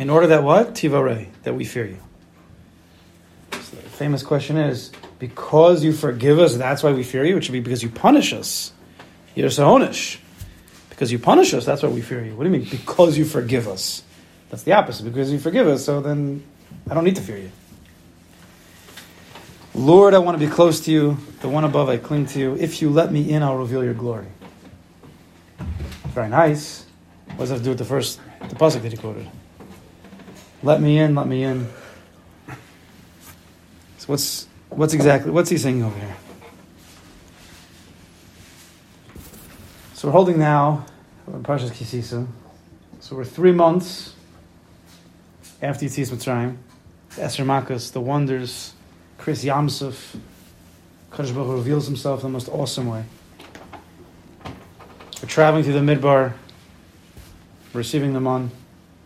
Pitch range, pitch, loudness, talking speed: 90-145 Hz, 125 Hz, -19 LUFS, 155 wpm